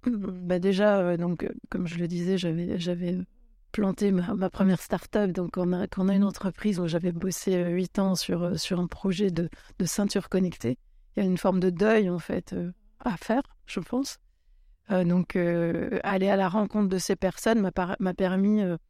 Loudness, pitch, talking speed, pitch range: -27 LUFS, 190 Hz, 215 wpm, 175-200 Hz